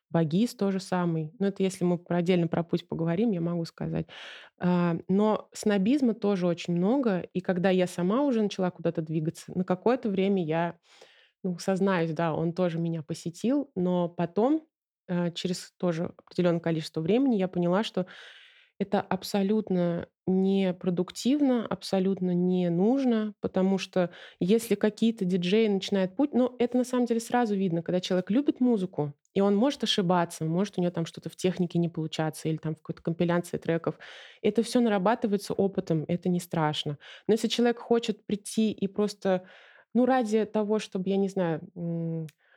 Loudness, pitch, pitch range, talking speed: -28 LUFS, 185 Hz, 175-215 Hz, 160 wpm